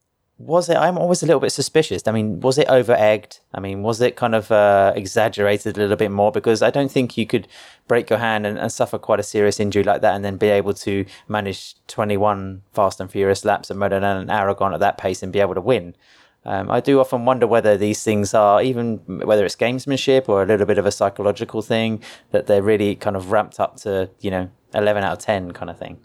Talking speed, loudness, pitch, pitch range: 245 wpm, -19 LUFS, 105 Hz, 100-115 Hz